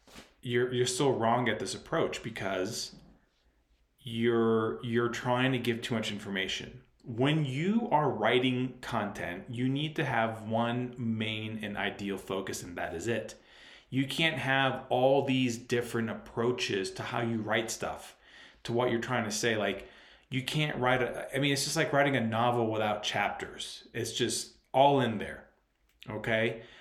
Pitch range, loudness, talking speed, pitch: 110-130 Hz, -31 LUFS, 165 wpm, 120 Hz